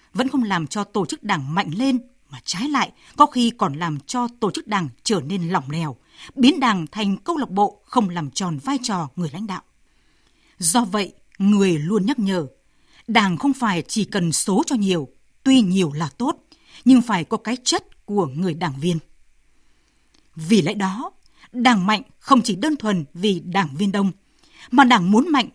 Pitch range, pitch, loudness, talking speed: 175-245 Hz, 205 Hz, -20 LUFS, 195 wpm